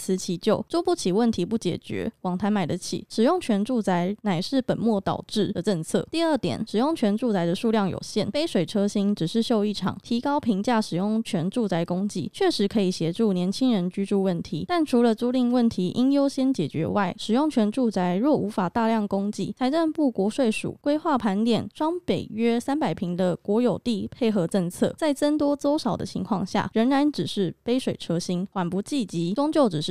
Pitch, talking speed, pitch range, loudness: 215 Hz, 300 characters per minute, 190-250 Hz, -25 LUFS